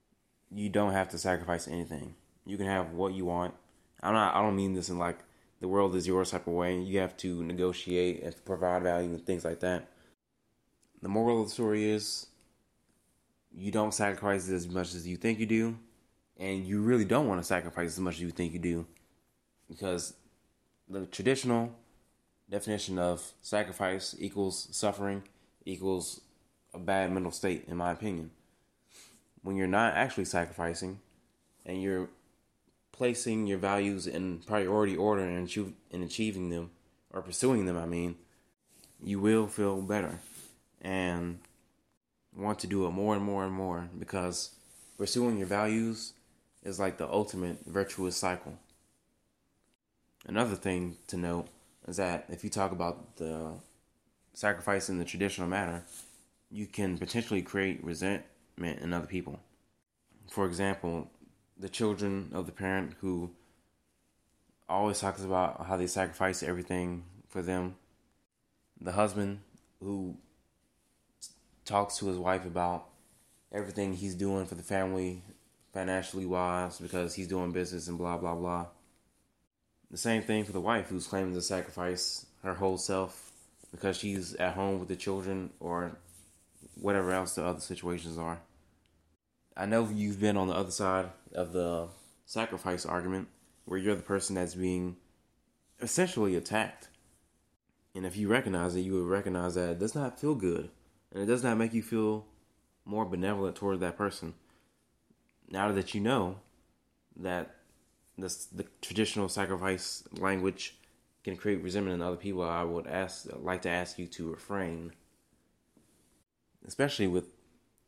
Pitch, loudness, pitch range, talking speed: 95 Hz, -33 LUFS, 90-100 Hz, 150 wpm